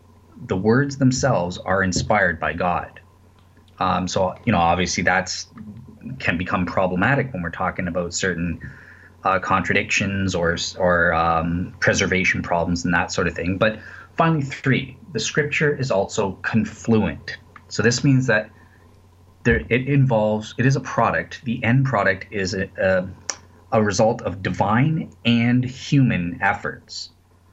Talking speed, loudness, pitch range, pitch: 140 wpm, -21 LUFS, 90-120 Hz, 100 Hz